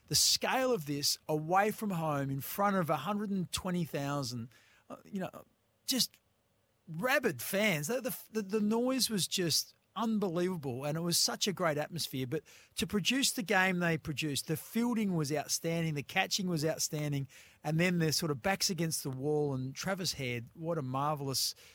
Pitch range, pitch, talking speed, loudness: 145-200 Hz, 165 Hz, 165 wpm, -33 LUFS